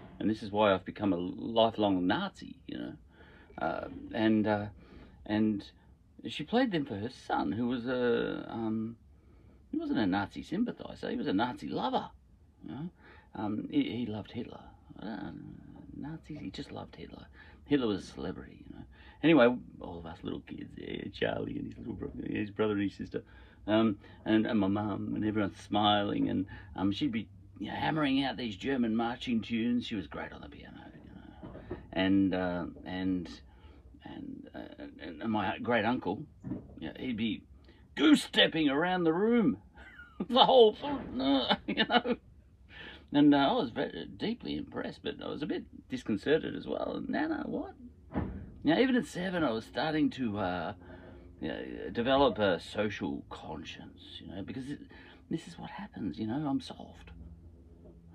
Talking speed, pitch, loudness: 170 wpm, 110 Hz, -32 LUFS